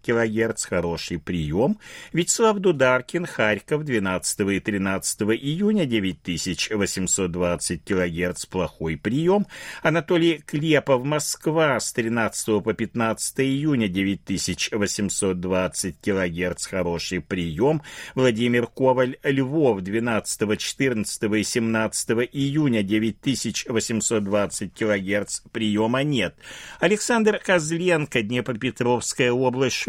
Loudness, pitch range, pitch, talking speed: -23 LUFS, 95-135 Hz, 110 Hz, 85 wpm